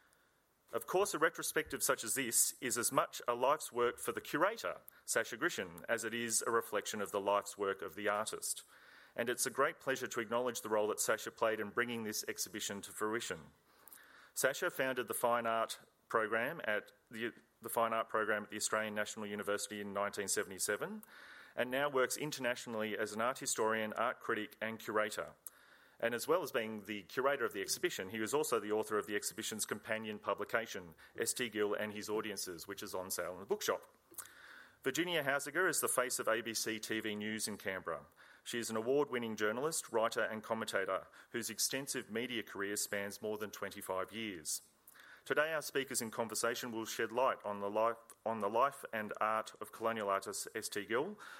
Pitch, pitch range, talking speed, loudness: 110 Hz, 105-120 Hz, 185 wpm, -37 LUFS